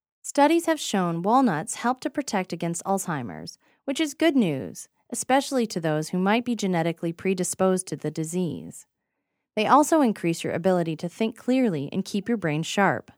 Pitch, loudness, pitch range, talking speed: 195 Hz, -25 LUFS, 170-255 Hz, 170 wpm